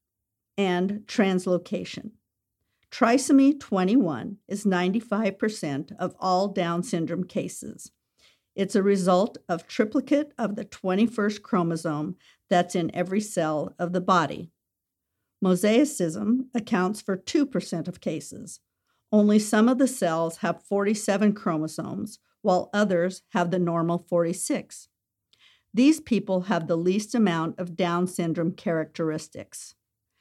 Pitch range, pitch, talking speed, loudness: 170-215 Hz, 185 Hz, 115 wpm, -25 LUFS